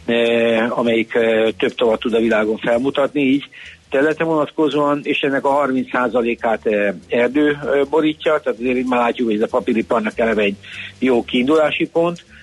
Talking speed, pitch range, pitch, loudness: 160 wpm, 115-145 Hz, 125 Hz, -17 LUFS